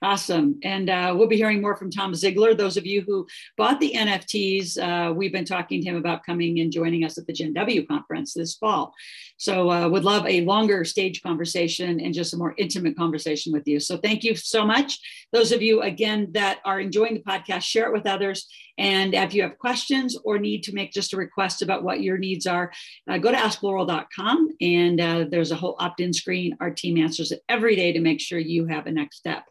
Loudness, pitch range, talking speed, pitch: -23 LUFS, 170-210 Hz, 230 wpm, 190 Hz